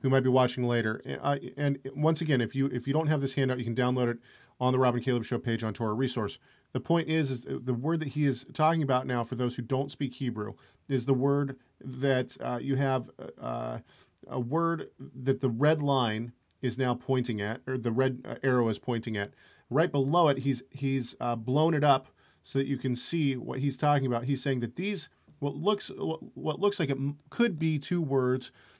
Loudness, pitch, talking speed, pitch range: -30 LUFS, 130 Hz, 220 wpm, 125-145 Hz